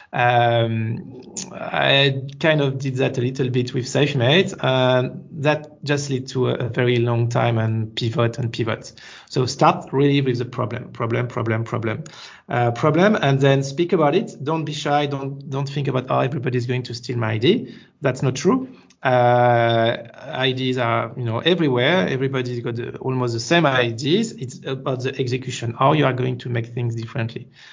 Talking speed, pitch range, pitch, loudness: 185 wpm, 120-140 Hz, 130 Hz, -20 LUFS